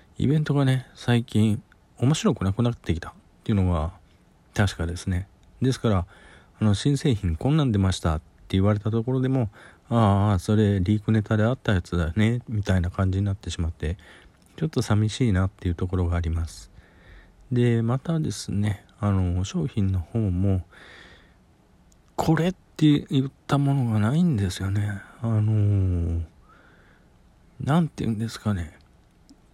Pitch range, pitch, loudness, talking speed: 90-120 Hz, 105 Hz, -25 LUFS, 305 characters per minute